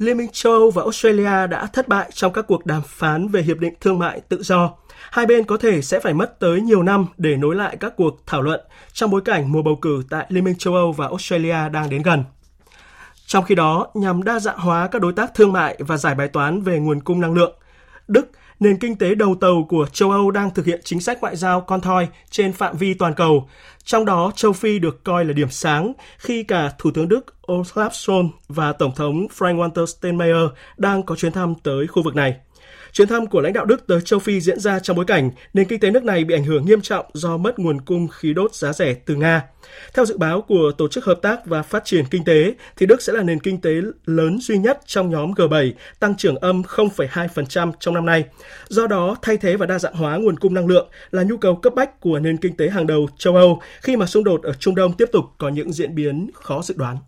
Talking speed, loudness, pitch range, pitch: 245 wpm, -18 LUFS, 160-205 Hz, 180 Hz